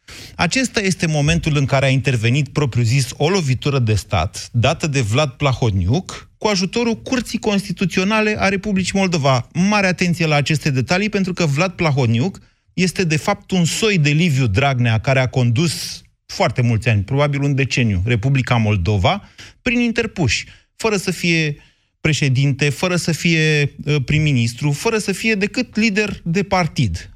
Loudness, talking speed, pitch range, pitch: -17 LUFS, 150 wpm, 130-190 Hz, 150 Hz